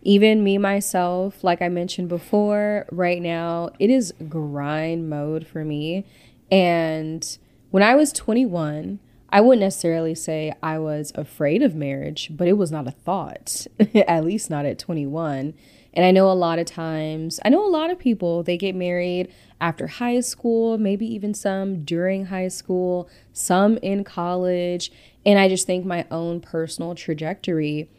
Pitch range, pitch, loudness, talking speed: 160-200 Hz, 175 Hz, -22 LUFS, 165 wpm